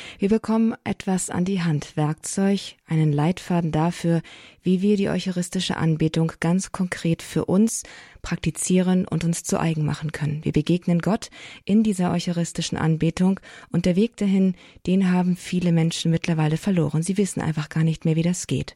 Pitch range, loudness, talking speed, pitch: 160-190 Hz, -23 LUFS, 165 wpm, 175 Hz